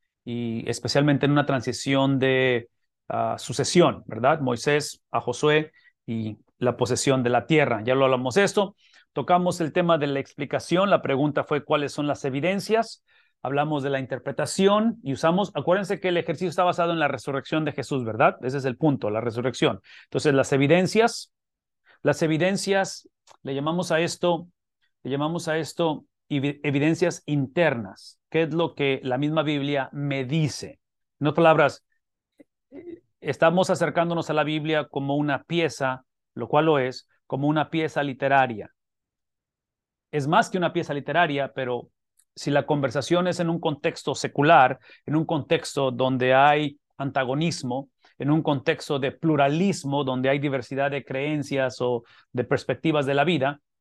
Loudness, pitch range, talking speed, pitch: -24 LUFS, 135-165 Hz, 155 wpm, 145 Hz